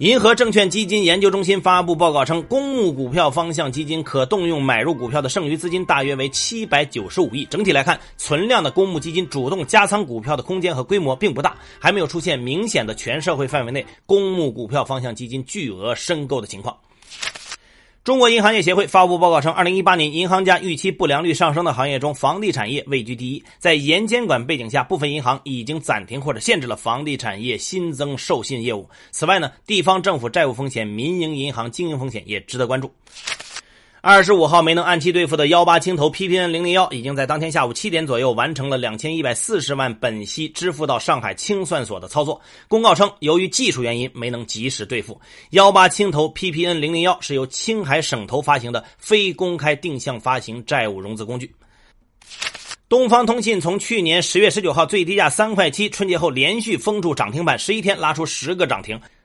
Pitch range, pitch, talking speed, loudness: 135-185 Hz, 165 Hz, 335 characters per minute, -18 LUFS